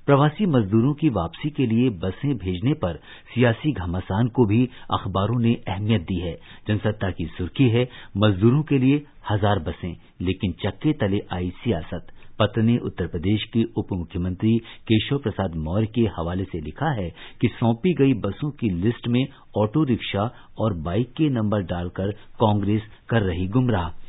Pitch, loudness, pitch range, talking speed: 110 Hz, -23 LUFS, 95-120 Hz, 160 wpm